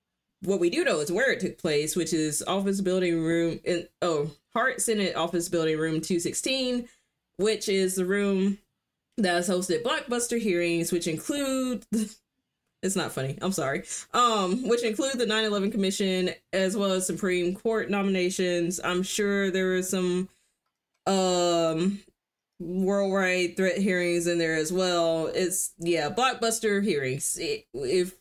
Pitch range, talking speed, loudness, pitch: 175-210 Hz, 150 wpm, -27 LUFS, 185 Hz